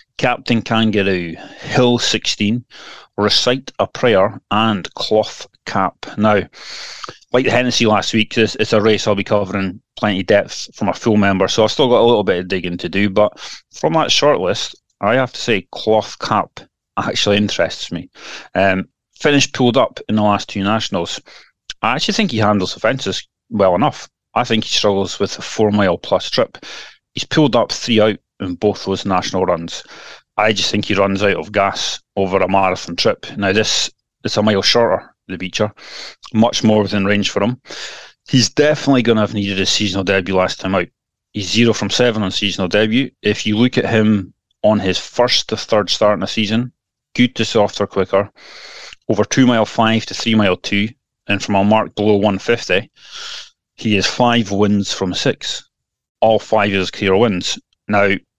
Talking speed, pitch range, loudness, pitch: 185 wpm, 100-115 Hz, -16 LUFS, 105 Hz